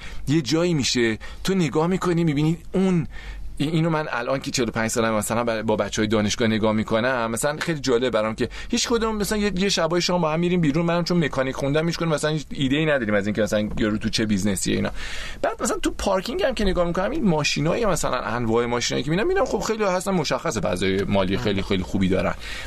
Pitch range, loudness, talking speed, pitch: 110-175 Hz, -23 LUFS, 210 wpm, 140 Hz